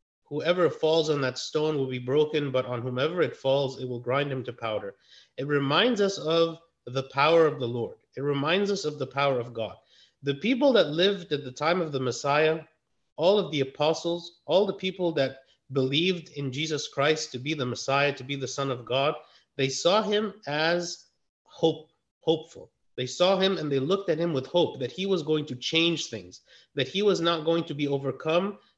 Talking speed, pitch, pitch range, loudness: 205 wpm, 150 Hz, 135-170 Hz, -27 LUFS